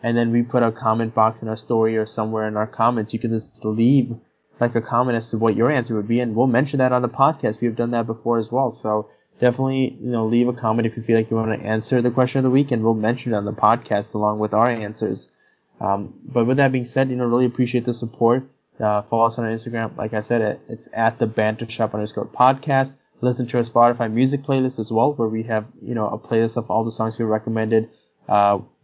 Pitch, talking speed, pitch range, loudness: 115 Hz, 255 wpm, 110-125 Hz, -21 LUFS